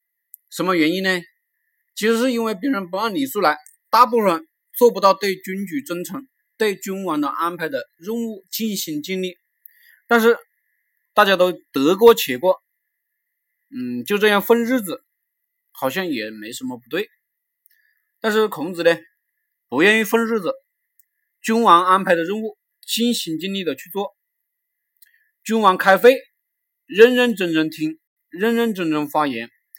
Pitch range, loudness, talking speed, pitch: 180-250 Hz, -19 LUFS, 215 characters per minute, 215 Hz